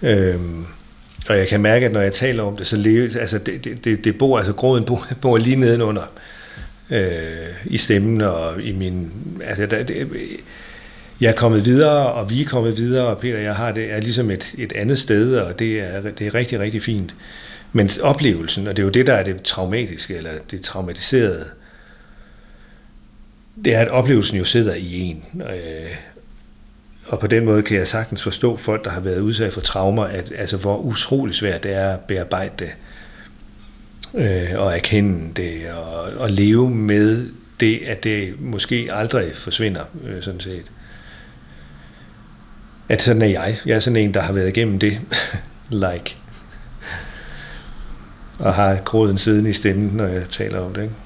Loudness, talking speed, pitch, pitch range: -19 LUFS, 175 wpm, 105 Hz, 95-115 Hz